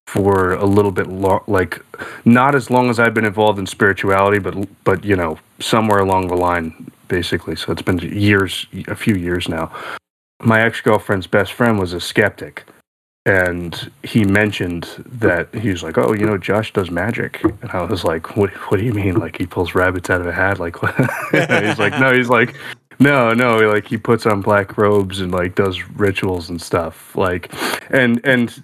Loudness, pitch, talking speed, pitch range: -17 LUFS, 100 Hz, 195 wpm, 90-115 Hz